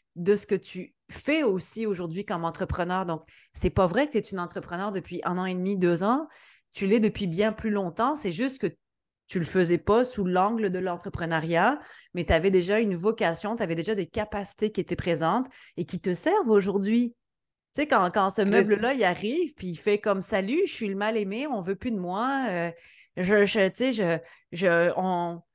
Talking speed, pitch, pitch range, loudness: 205 wpm, 195 Hz, 180-215 Hz, -26 LUFS